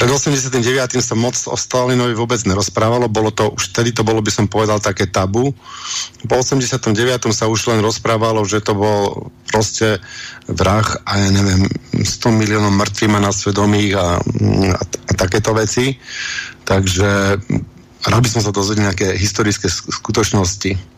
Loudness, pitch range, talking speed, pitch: -16 LUFS, 100-120 Hz, 150 wpm, 110 Hz